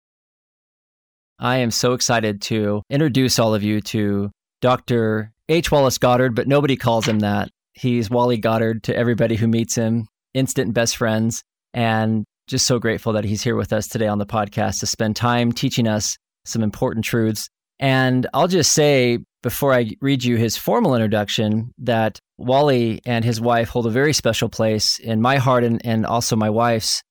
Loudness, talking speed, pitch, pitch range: -19 LUFS, 175 wpm, 115 Hz, 110-125 Hz